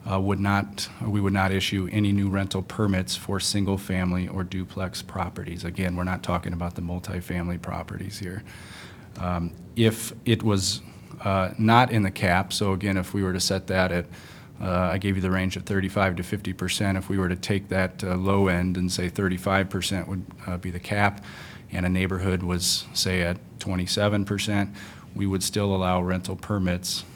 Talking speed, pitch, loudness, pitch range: 190 wpm, 95 Hz, -26 LUFS, 90-100 Hz